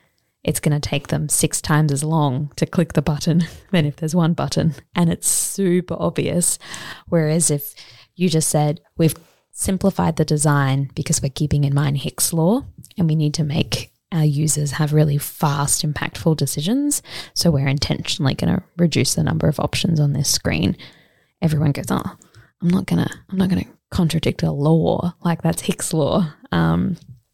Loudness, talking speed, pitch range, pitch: -20 LUFS, 175 wpm, 145-170 Hz, 155 Hz